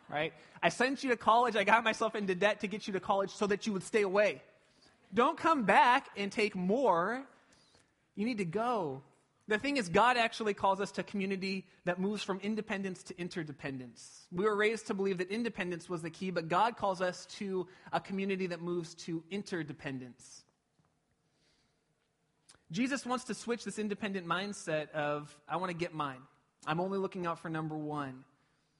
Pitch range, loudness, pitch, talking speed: 165-215 Hz, -33 LUFS, 190 Hz, 185 wpm